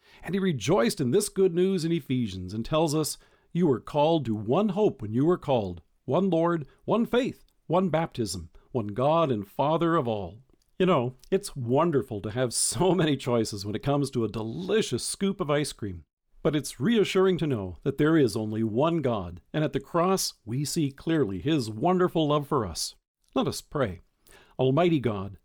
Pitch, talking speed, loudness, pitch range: 145 Hz, 190 wpm, -27 LUFS, 115-175 Hz